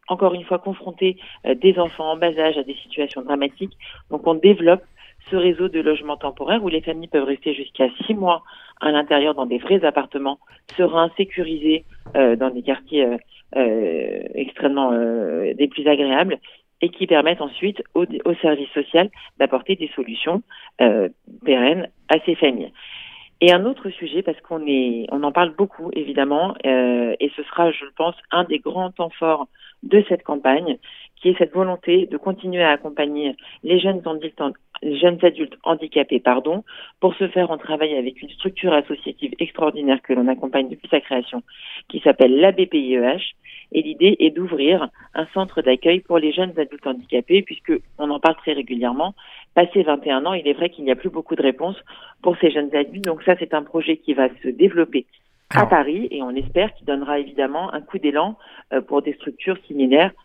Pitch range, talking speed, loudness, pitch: 140-180 Hz, 185 wpm, -20 LUFS, 155 Hz